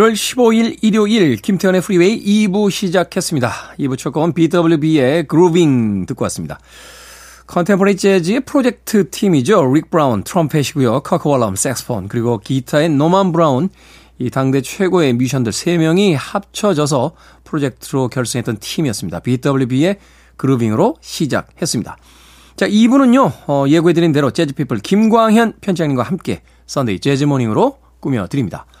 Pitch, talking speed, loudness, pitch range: 160 Hz, 340 characters per minute, -15 LUFS, 130-195 Hz